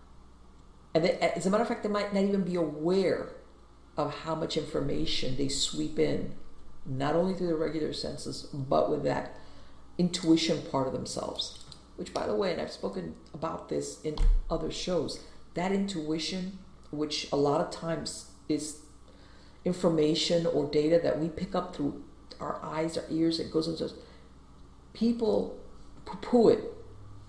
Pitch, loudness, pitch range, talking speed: 155 Hz, -30 LUFS, 130-175 Hz, 155 wpm